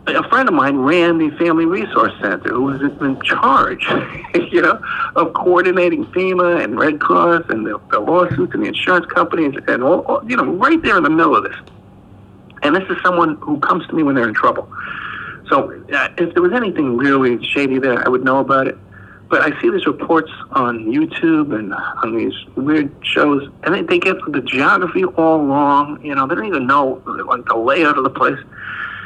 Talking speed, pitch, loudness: 205 wpm, 170 Hz, -15 LUFS